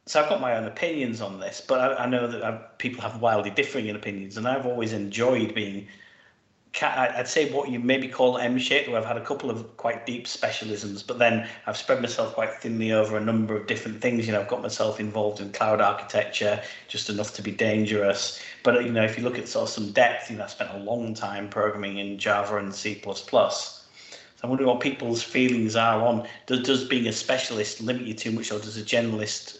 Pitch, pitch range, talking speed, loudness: 110 Hz, 105-120 Hz, 225 wpm, -26 LUFS